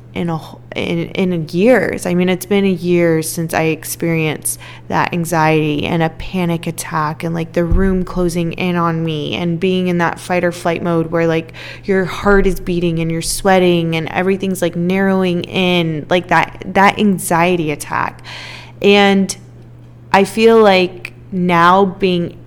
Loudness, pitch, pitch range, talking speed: -15 LUFS, 175 Hz, 165-185 Hz, 165 wpm